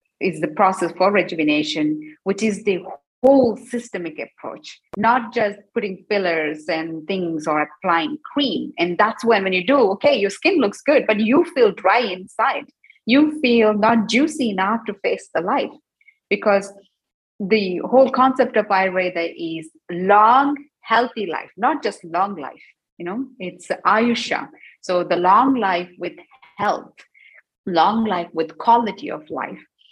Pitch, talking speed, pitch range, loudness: 205 Hz, 150 wpm, 180-245 Hz, -19 LUFS